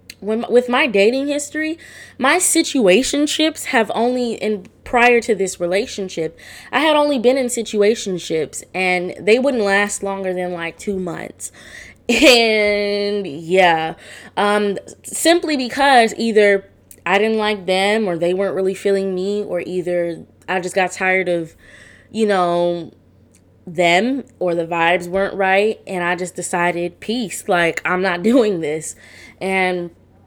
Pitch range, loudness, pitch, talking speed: 175-225 Hz, -17 LUFS, 195 Hz, 140 wpm